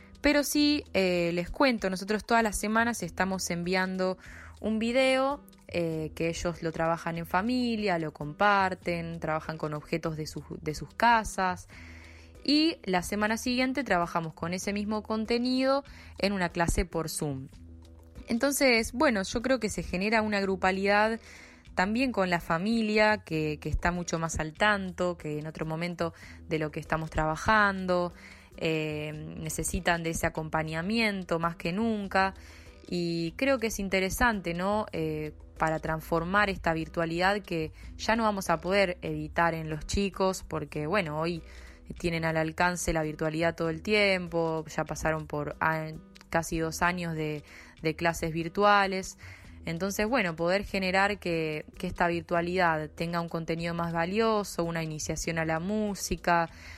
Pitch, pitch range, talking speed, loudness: 175 Hz, 160-205 Hz, 150 wpm, -29 LUFS